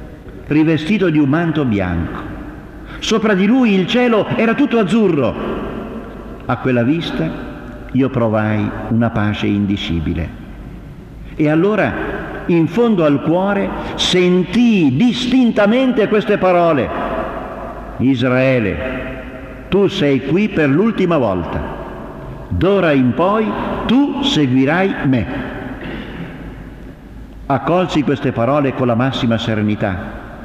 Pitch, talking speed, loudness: 145 Hz, 100 wpm, -15 LUFS